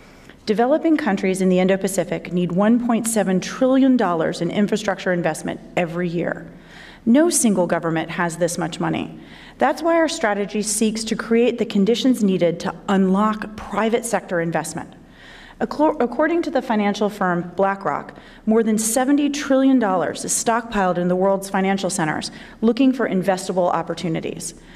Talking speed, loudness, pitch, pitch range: 140 wpm, -20 LUFS, 205 Hz, 180-235 Hz